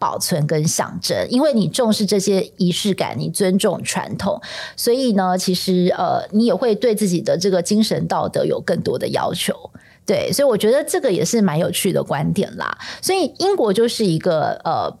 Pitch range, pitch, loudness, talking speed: 180-235 Hz, 205 Hz, -18 LUFS, 285 characters per minute